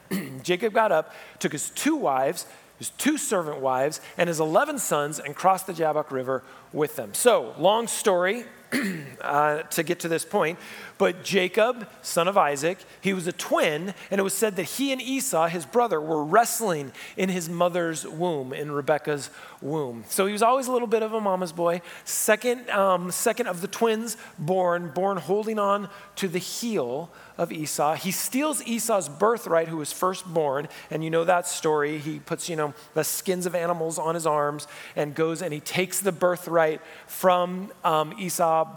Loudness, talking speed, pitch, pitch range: -25 LUFS, 185 wpm, 180 Hz, 155-200 Hz